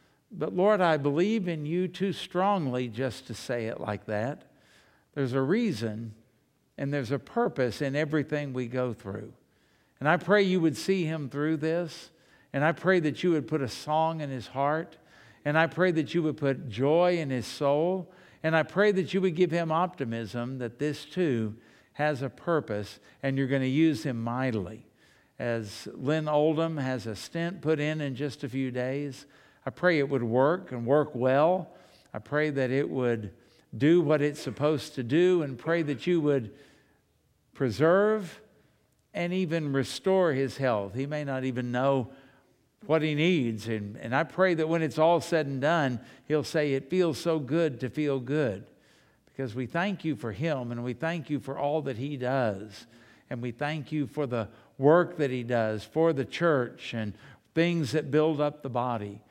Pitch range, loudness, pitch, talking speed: 125-160 Hz, -28 LUFS, 145 Hz, 190 wpm